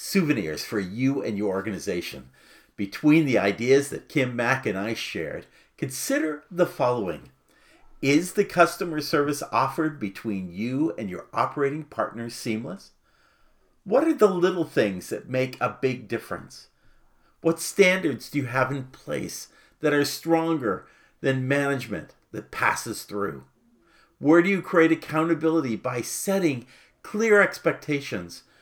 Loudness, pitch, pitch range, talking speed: -25 LUFS, 145 Hz, 120-165 Hz, 135 wpm